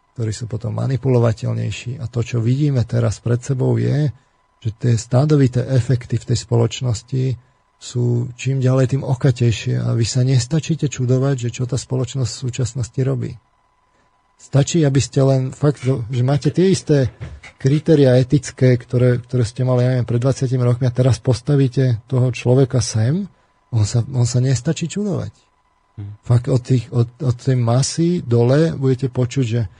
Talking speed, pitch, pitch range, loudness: 160 wpm, 125 Hz, 120-135 Hz, -18 LUFS